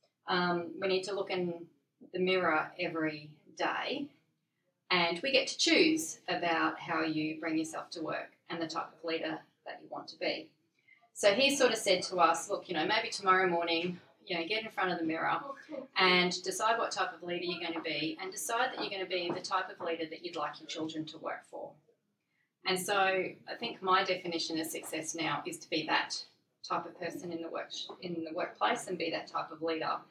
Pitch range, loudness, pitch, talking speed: 165-190 Hz, -33 LUFS, 175 Hz, 220 wpm